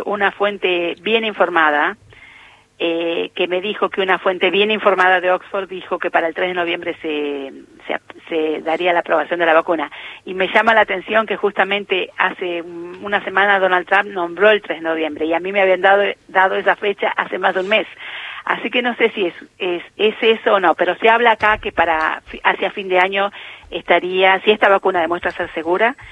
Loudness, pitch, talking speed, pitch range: -17 LUFS, 190 Hz, 205 wpm, 175-205 Hz